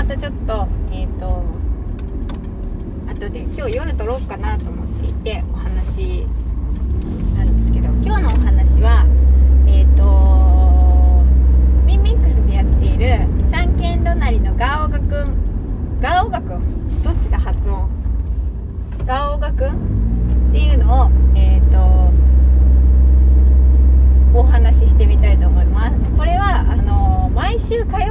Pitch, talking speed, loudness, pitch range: 65 Hz, 235 characters per minute, -16 LUFS, 65-80 Hz